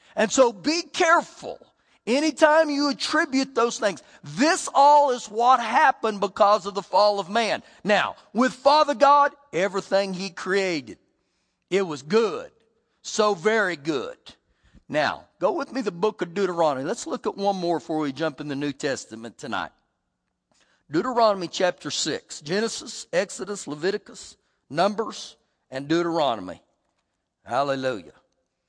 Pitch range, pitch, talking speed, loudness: 175-270 Hz, 210 Hz, 135 wpm, -23 LUFS